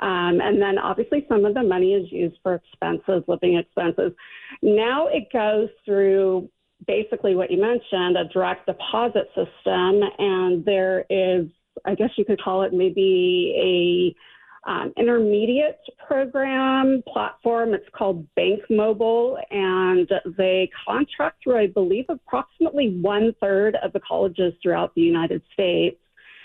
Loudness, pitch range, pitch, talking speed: -21 LUFS, 185-240 Hz, 200 Hz, 140 wpm